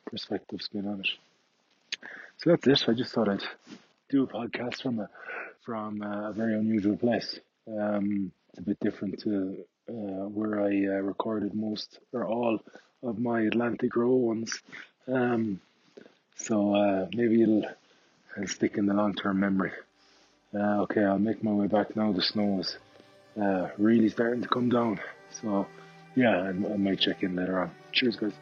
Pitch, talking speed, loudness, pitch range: 105 Hz, 170 wpm, -29 LUFS, 100-115 Hz